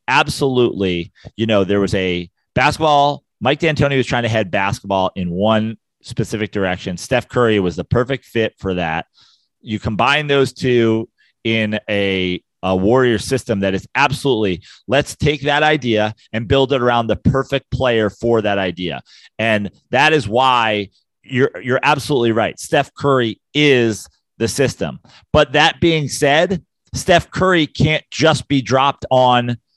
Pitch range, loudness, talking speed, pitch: 105-135 Hz, -17 LUFS, 155 wpm, 120 Hz